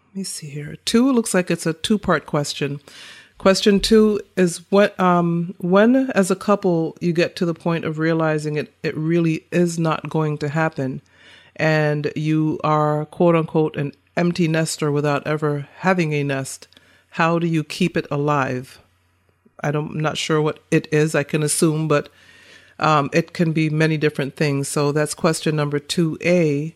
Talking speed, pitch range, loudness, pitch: 180 wpm, 150-175 Hz, -20 LUFS, 160 Hz